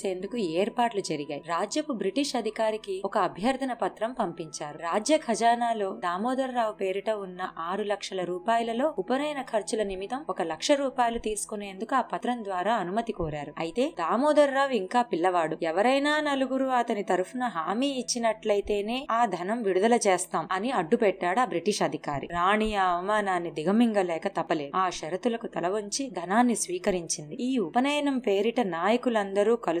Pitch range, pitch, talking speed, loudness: 185-245 Hz, 210 Hz, 135 wpm, -27 LUFS